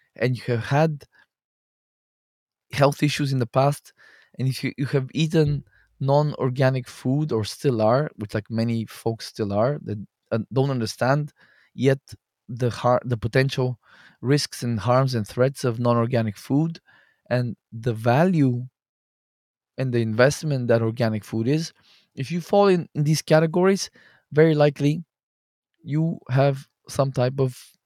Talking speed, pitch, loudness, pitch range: 145 wpm, 130 Hz, -23 LUFS, 120-145 Hz